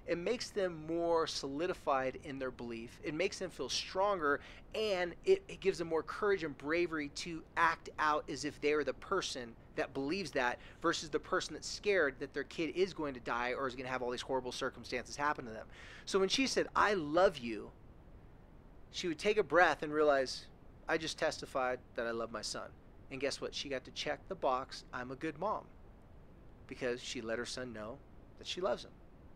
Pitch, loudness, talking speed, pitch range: 150 Hz, -36 LUFS, 210 wpm, 125-170 Hz